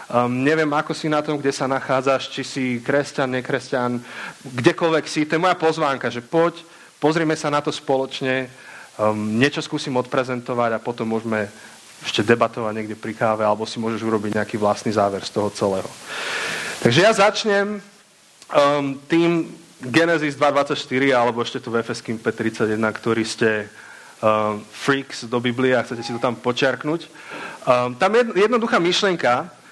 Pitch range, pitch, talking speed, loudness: 115-155 Hz, 130 Hz, 160 wpm, -21 LUFS